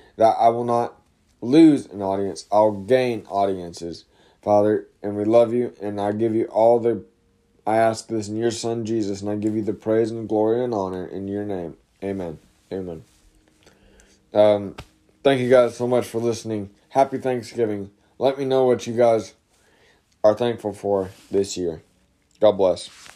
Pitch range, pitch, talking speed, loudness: 100-115 Hz, 105 Hz, 170 wpm, -21 LUFS